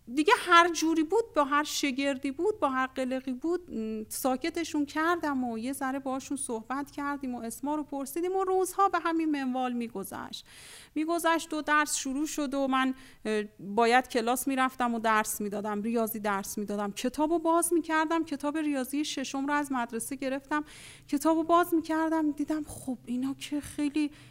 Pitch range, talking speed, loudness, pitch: 255-315 Hz, 165 wpm, -29 LUFS, 285 Hz